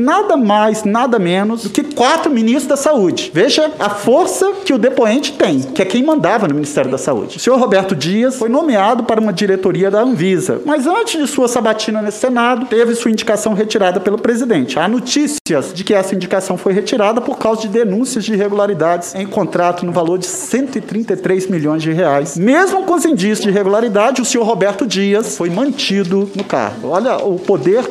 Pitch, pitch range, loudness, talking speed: 220 Hz, 195-255 Hz, -14 LUFS, 190 wpm